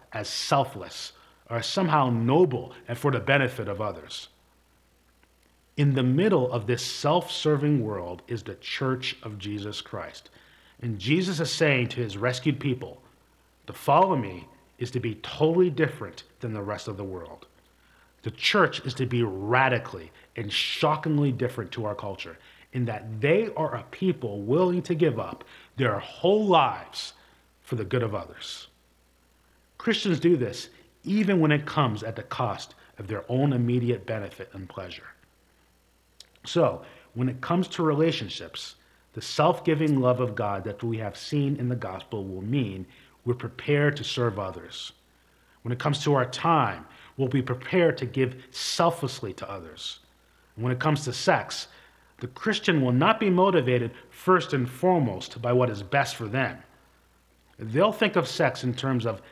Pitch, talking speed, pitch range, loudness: 125 Hz, 165 wpm, 100-150 Hz, -26 LUFS